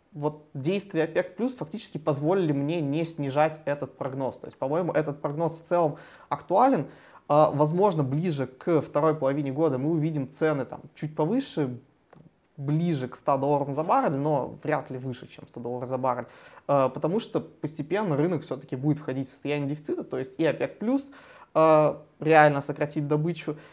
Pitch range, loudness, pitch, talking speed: 140-160 Hz, -27 LUFS, 150 Hz, 160 wpm